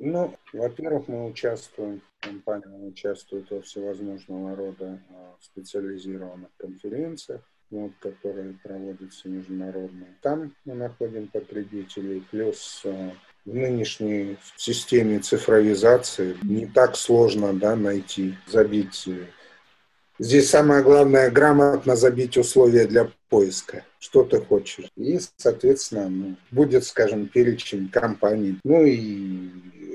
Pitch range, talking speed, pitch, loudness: 95-125 Hz, 100 wpm, 105 Hz, -21 LUFS